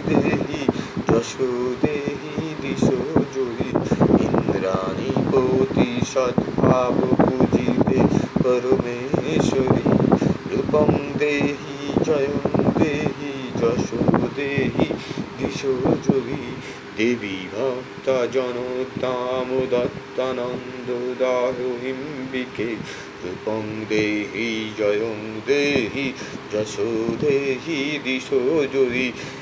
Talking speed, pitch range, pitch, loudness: 45 wpm, 120-135 Hz, 130 Hz, -22 LUFS